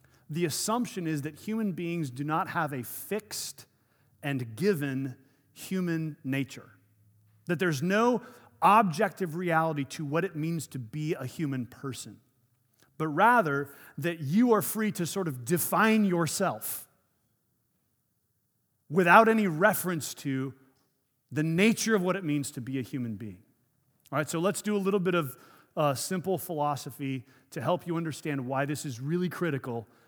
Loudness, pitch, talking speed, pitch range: -29 LUFS, 155 Hz, 150 wpm, 130-180 Hz